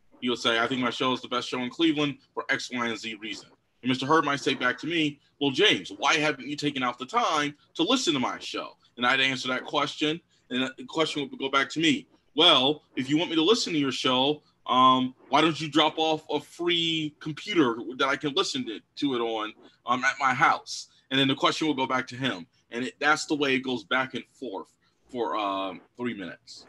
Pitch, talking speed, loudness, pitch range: 145 Hz, 245 wpm, -26 LUFS, 130-155 Hz